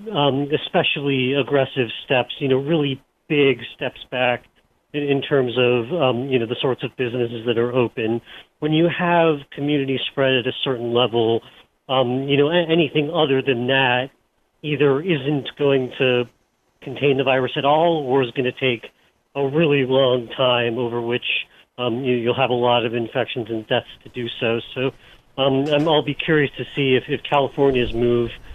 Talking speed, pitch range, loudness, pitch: 180 wpm, 125-145 Hz, -20 LUFS, 130 Hz